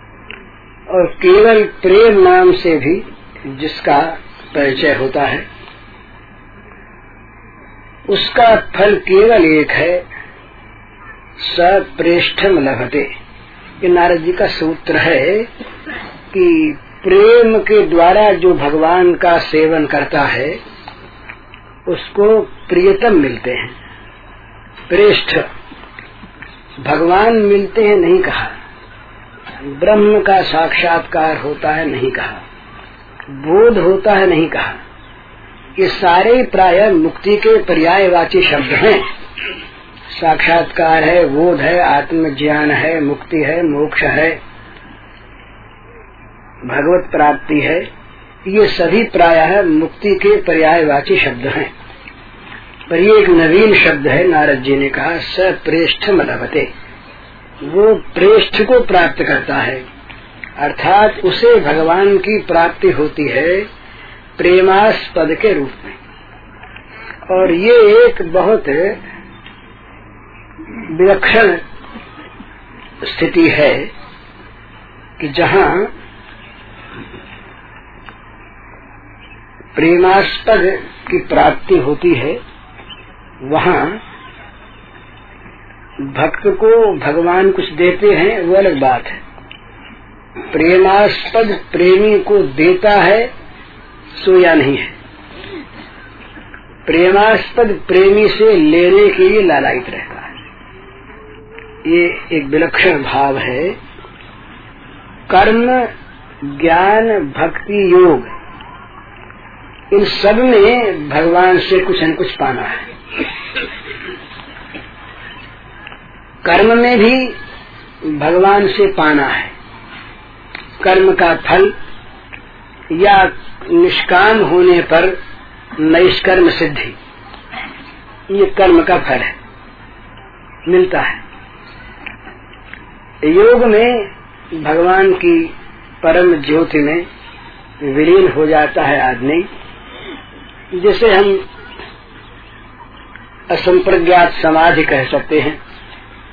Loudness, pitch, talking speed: -11 LUFS, 175 Hz, 90 wpm